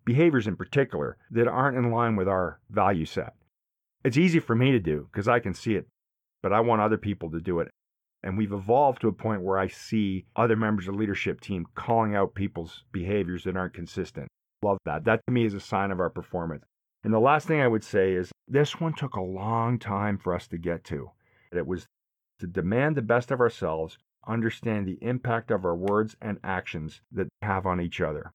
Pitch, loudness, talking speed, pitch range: 105 Hz, -27 LUFS, 220 wpm, 95-115 Hz